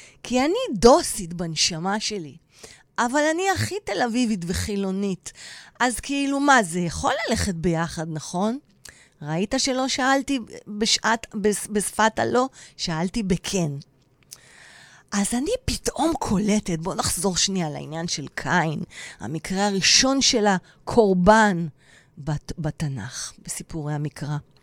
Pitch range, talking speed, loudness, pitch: 160-235 Hz, 110 wpm, -23 LUFS, 195 Hz